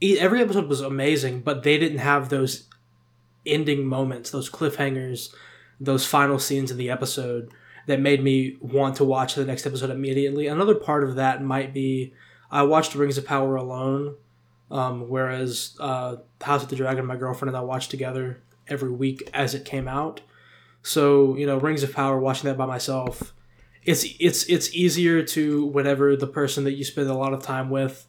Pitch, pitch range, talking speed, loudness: 135 Hz, 130-145 Hz, 185 wpm, -24 LUFS